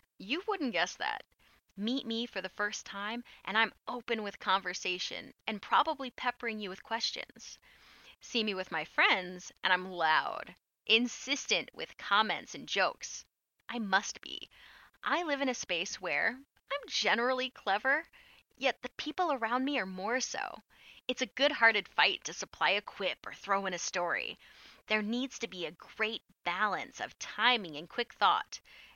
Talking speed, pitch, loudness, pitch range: 165 wpm, 225 Hz, -33 LUFS, 195-255 Hz